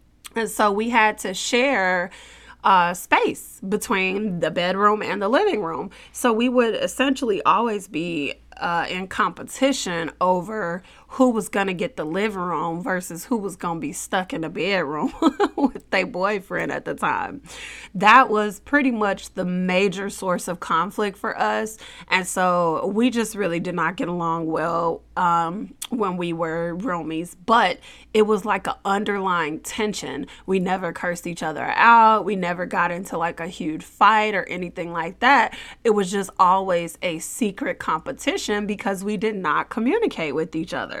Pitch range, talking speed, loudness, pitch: 170-215 Hz, 165 wpm, -22 LUFS, 190 Hz